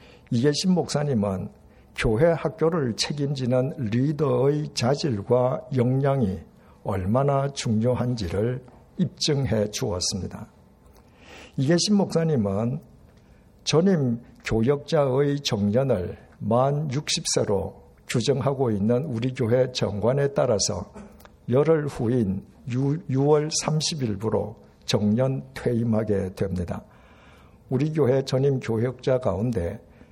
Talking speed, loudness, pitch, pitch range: 210 characters per minute, -24 LUFS, 130 Hz, 110-145 Hz